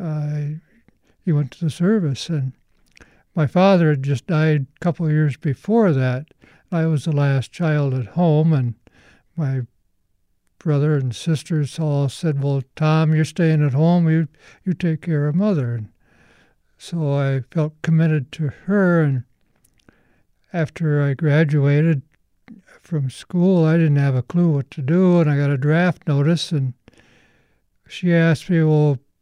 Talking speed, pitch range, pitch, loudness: 155 wpm, 140-165 Hz, 150 Hz, -19 LUFS